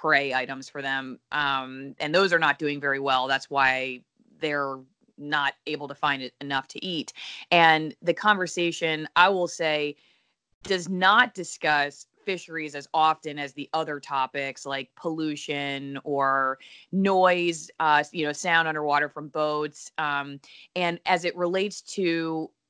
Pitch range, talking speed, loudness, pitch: 140-170 Hz, 150 wpm, -25 LUFS, 150 Hz